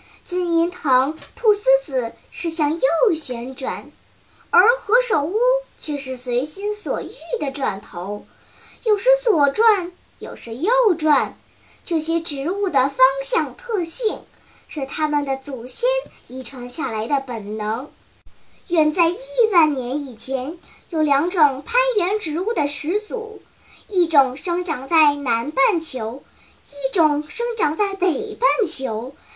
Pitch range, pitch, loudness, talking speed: 270-440 Hz, 330 Hz, -20 LUFS, 180 characters per minute